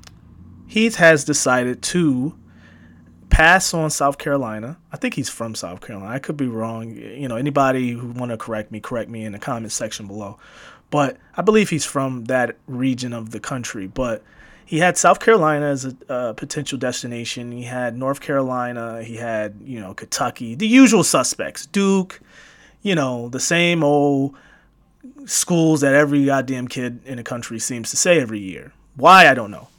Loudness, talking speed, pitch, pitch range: -19 LUFS, 175 wpm, 130 Hz, 115-150 Hz